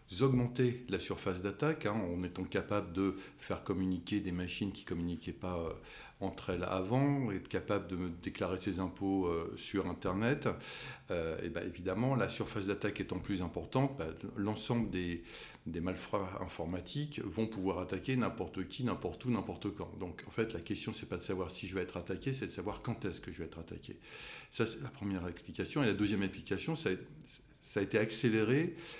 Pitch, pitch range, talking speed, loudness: 100 Hz, 90-110 Hz, 195 wpm, -37 LUFS